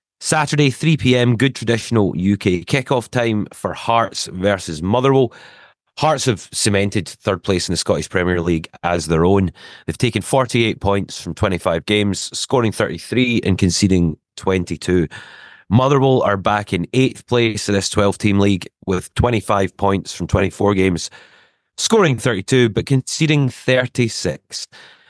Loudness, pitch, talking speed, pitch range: -18 LUFS, 105 Hz, 140 wpm, 95-125 Hz